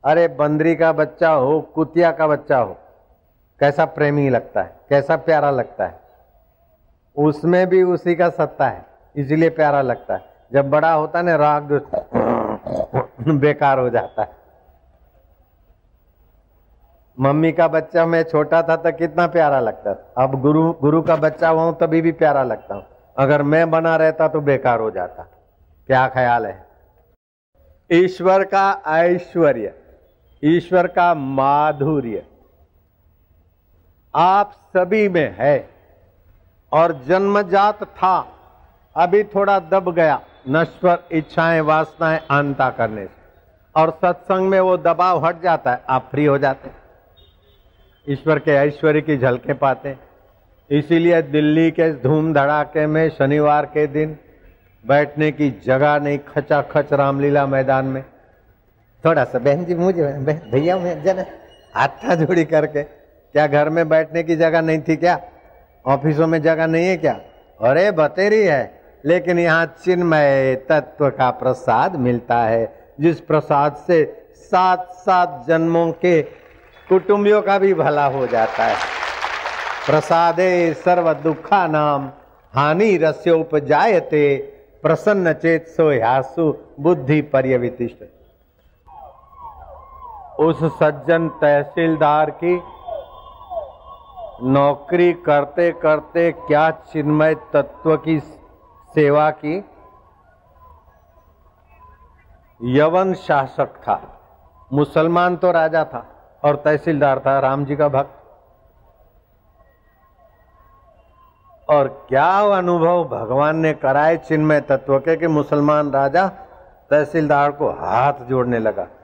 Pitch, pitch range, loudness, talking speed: 150 Hz, 135-165 Hz, -17 LUFS, 120 wpm